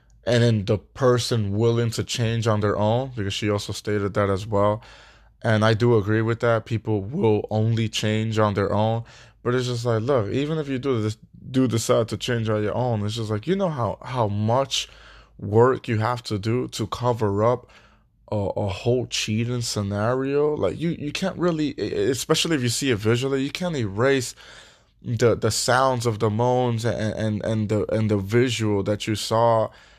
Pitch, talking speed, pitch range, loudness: 115 Hz, 195 wpm, 110-125 Hz, -23 LUFS